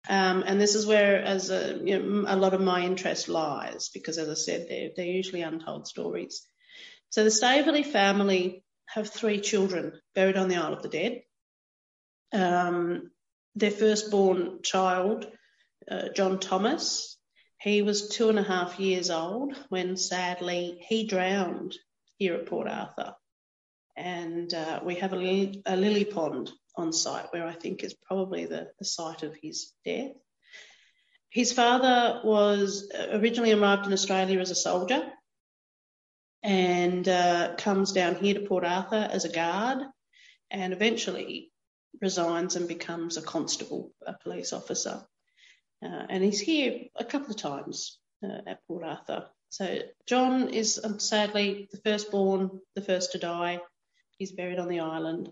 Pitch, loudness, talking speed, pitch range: 195 Hz, -28 LUFS, 155 wpm, 180-215 Hz